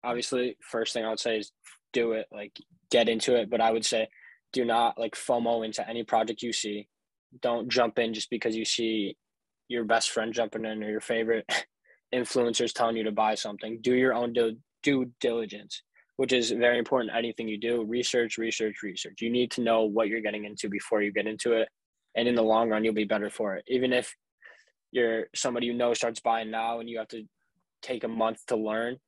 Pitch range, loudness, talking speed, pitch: 110-120 Hz, -28 LUFS, 215 wpm, 115 Hz